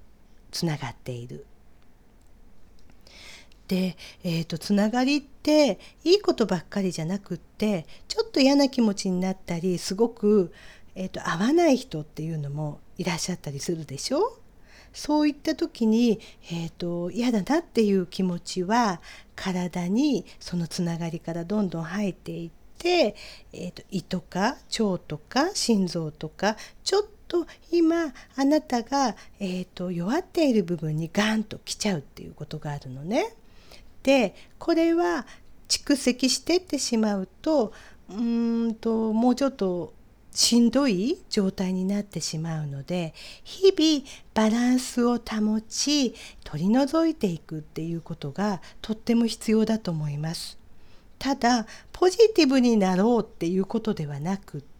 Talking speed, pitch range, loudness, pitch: 295 characters per minute, 175-260 Hz, -26 LUFS, 210 Hz